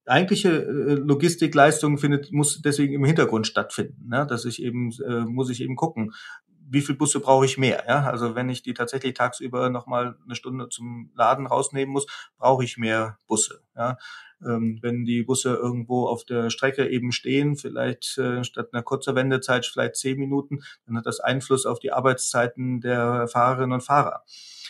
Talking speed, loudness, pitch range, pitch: 175 wpm, -24 LUFS, 120-140 Hz, 125 Hz